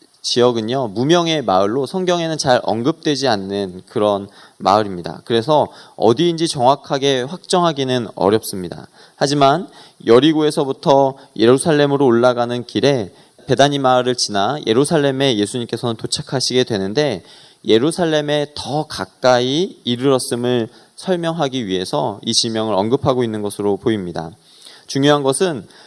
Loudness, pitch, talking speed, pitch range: -17 LUFS, 130 Hz, 325 characters per minute, 115-150 Hz